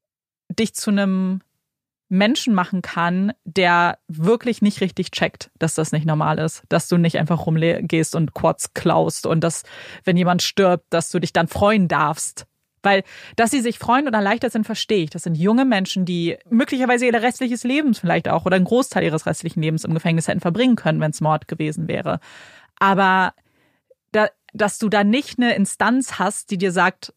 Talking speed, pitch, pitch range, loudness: 185 wpm, 185 Hz, 165-220 Hz, -19 LUFS